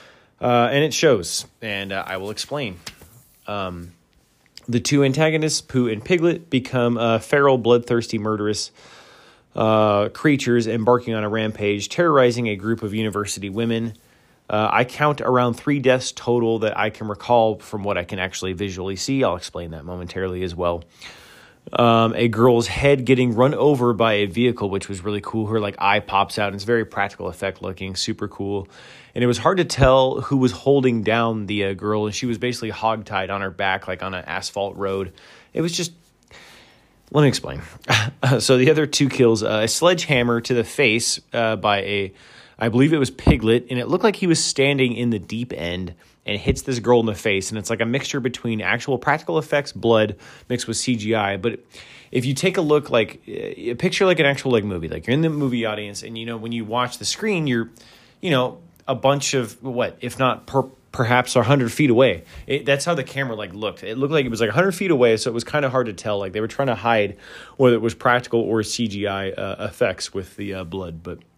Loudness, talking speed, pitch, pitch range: -20 LUFS, 210 wpm, 115 Hz, 105-130 Hz